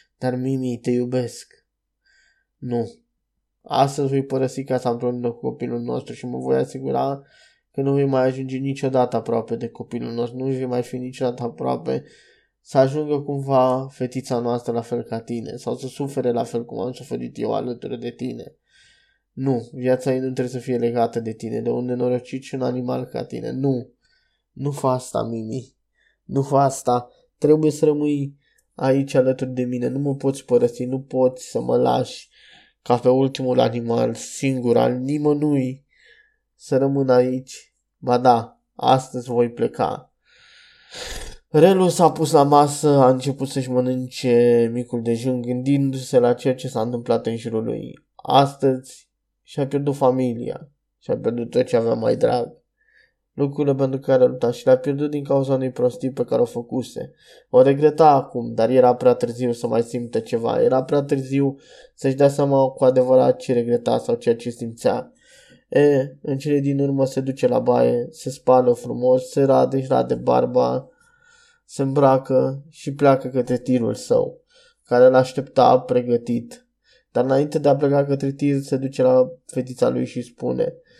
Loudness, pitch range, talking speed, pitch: -21 LUFS, 125-140 Hz, 165 wpm, 130 Hz